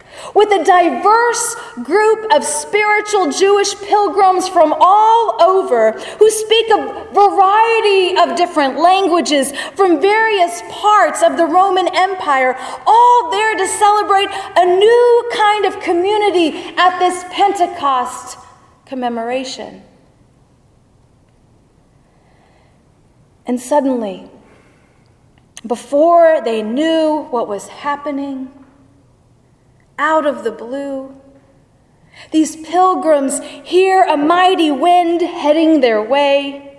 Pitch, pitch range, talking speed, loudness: 345 Hz, 280-395 Hz, 95 wpm, -13 LUFS